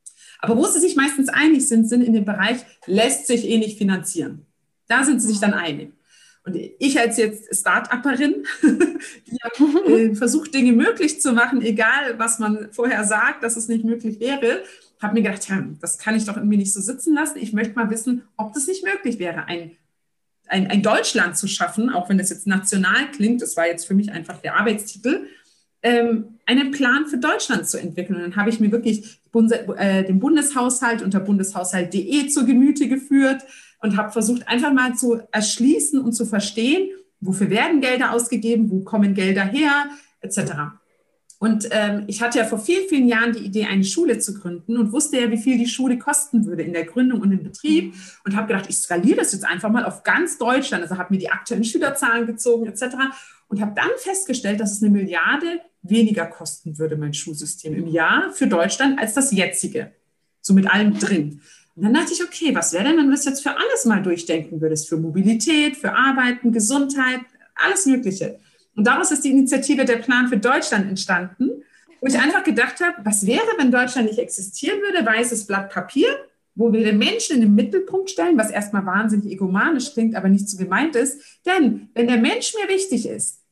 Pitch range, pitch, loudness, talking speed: 200-270 Hz, 230 Hz, -19 LUFS, 195 wpm